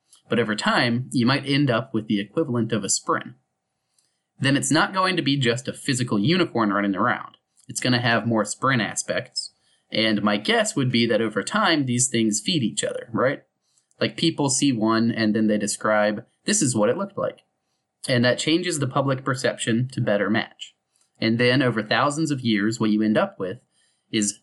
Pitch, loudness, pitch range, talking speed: 120 Hz, -22 LUFS, 110-140 Hz, 200 wpm